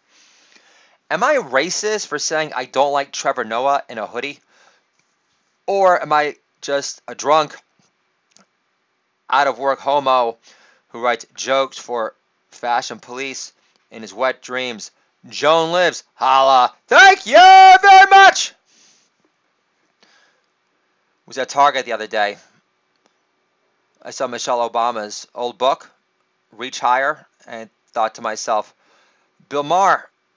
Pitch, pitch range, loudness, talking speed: 135 Hz, 125-165 Hz, -15 LUFS, 120 wpm